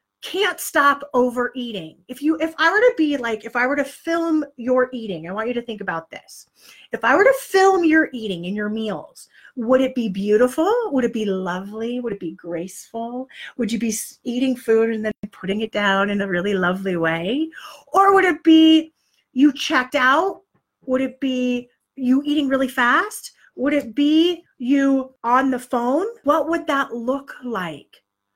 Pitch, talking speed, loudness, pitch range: 255 Hz, 185 wpm, -20 LUFS, 220-295 Hz